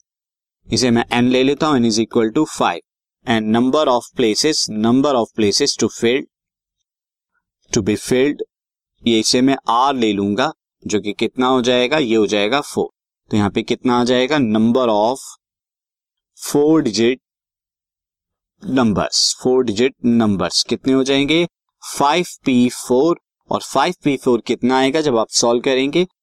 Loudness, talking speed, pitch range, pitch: -16 LUFS, 155 wpm, 115-135 Hz, 125 Hz